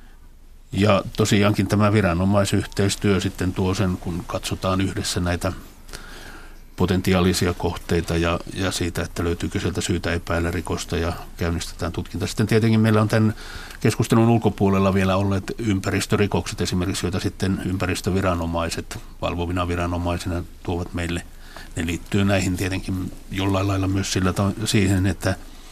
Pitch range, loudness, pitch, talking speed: 85-100 Hz, -22 LUFS, 95 Hz, 125 wpm